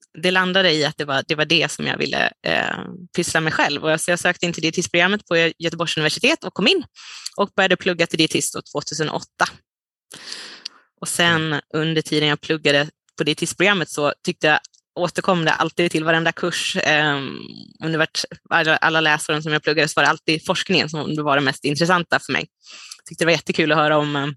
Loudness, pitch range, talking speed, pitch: -19 LUFS, 150-175 Hz, 195 wpm, 160 Hz